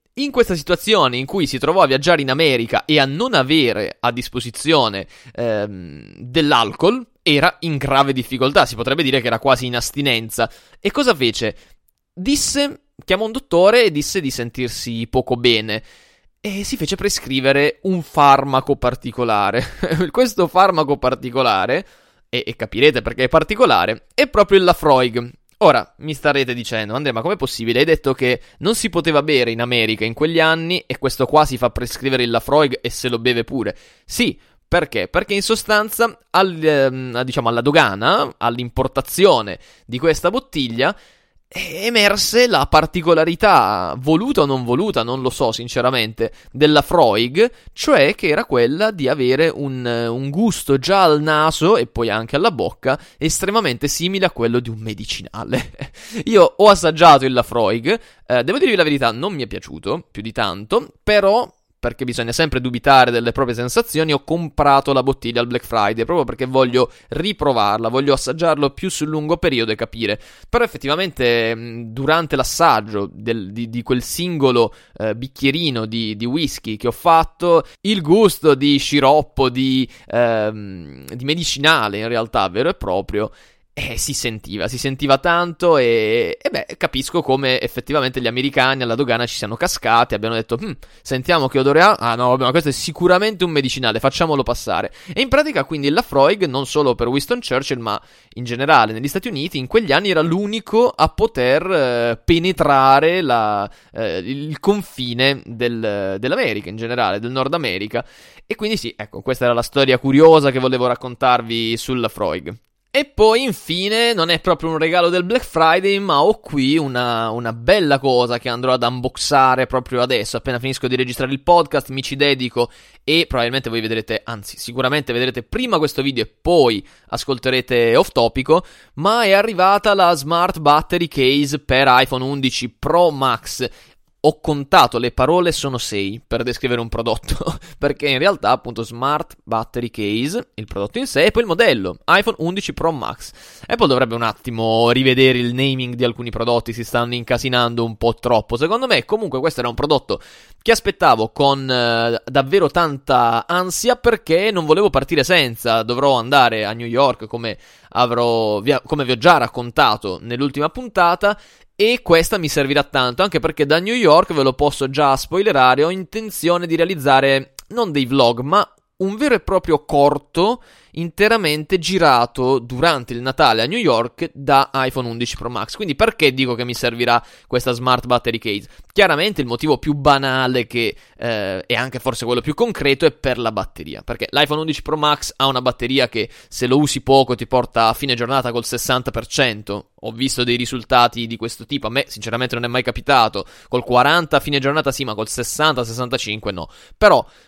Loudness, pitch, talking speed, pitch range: -17 LUFS, 135 Hz, 170 wpm, 120-160 Hz